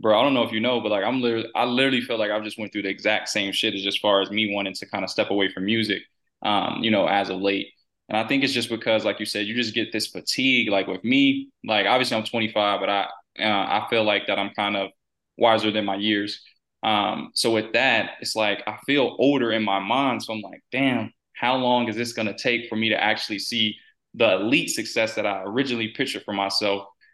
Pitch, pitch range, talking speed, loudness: 110 Hz, 100-120 Hz, 250 wpm, -23 LUFS